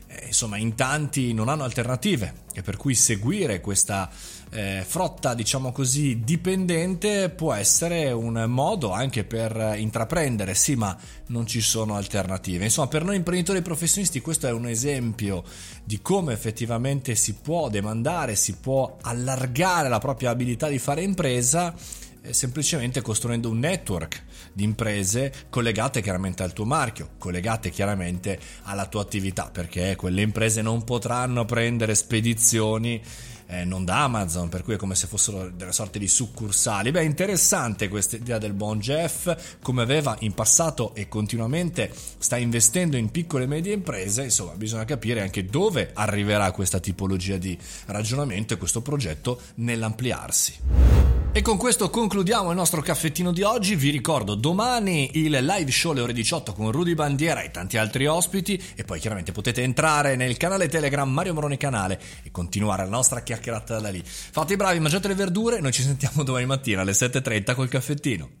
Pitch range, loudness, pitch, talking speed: 105-150 Hz, -24 LUFS, 120 Hz, 160 wpm